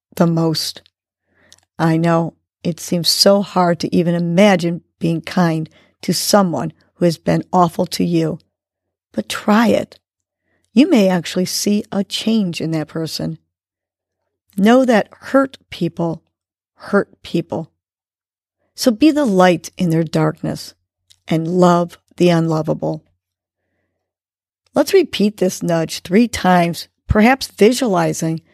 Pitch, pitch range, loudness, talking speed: 170 Hz, 145-190 Hz, -16 LUFS, 120 wpm